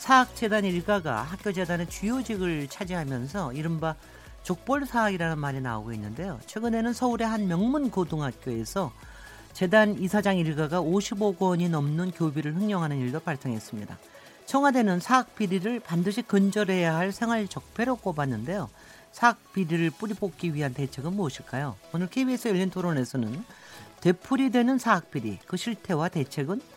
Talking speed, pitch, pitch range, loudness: 350 characters per minute, 185 Hz, 150-215 Hz, -27 LUFS